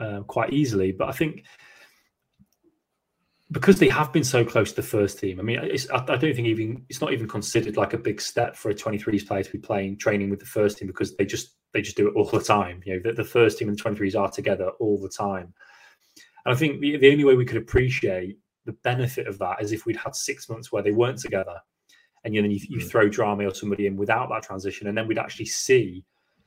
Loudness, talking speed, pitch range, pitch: -24 LUFS, 250 wpm, 100-130 Hz, 110 Hz